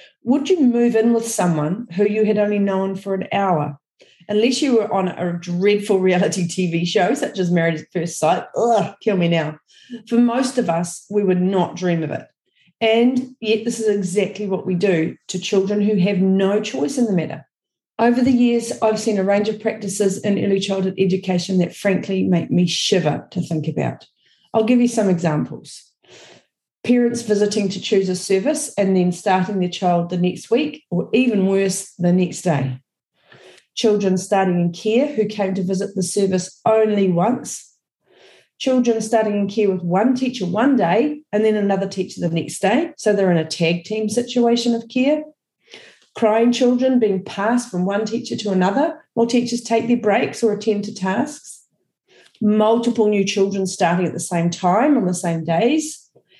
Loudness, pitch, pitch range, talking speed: -19 LUFS, 200 Hz, 180-230 Hz, 185 wpm